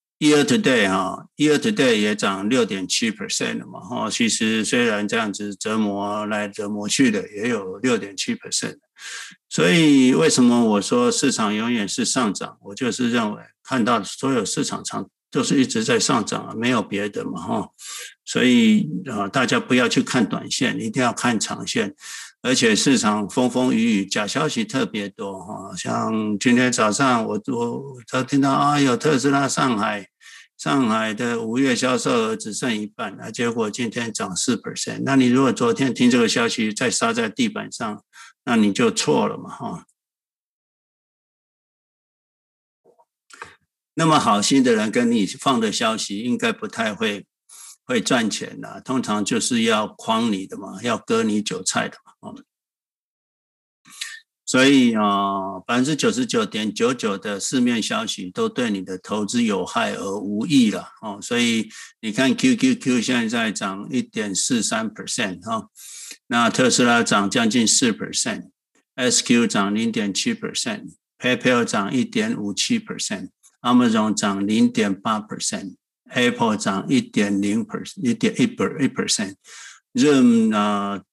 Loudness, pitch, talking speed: -20 LUFS, 225 Hz, 285 characters per minute